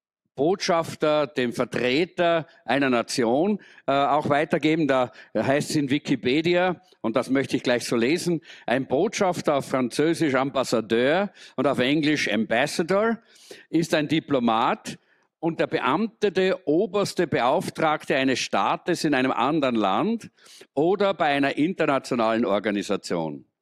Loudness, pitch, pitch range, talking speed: -24 LUFS, 150 Hz, 130-175 Hz, 120 wpm